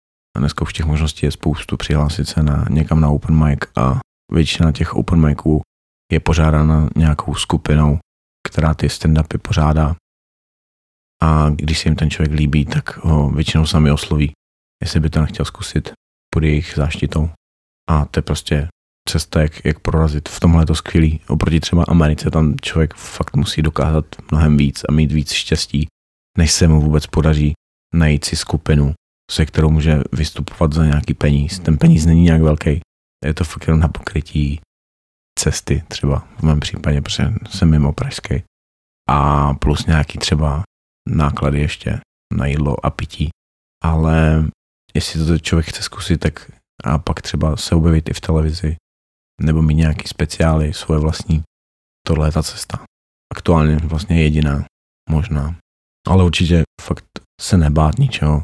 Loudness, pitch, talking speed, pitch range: -17 LUFS, 75 Hz, 155 wpm, 75-80 Hz